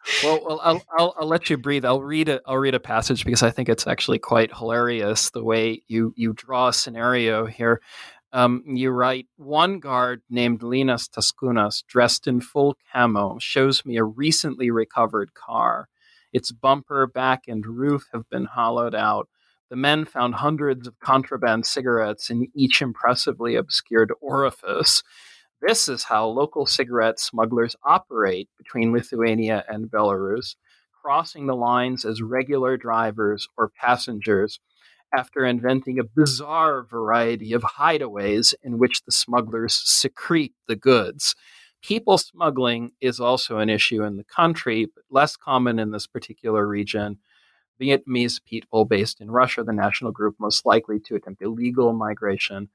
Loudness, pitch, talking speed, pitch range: -22 LUFS, 120 Hz, 150 wpm, 110-130 Hz